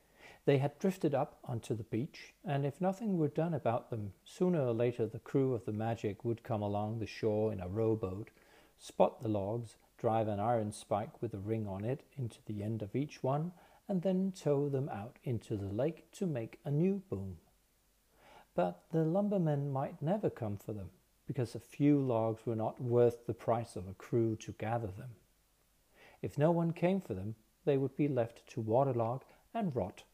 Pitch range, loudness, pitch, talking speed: 110-150 Hz, -36 LUFS, 120 Hz, 195 wpm